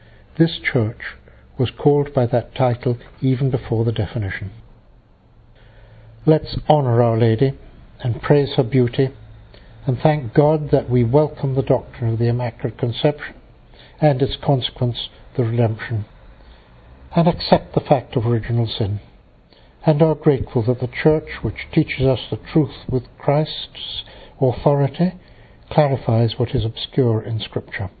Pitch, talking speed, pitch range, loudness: 125 Hz, 135 wpm, 115-145 Hz, -20 LUFS